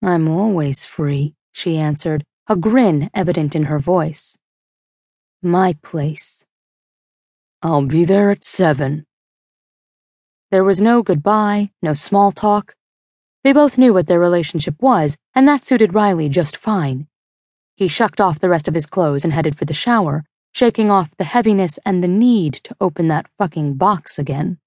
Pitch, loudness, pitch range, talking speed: 180 Hz, -16 LUFS, 155-205 Hz, 155 wpm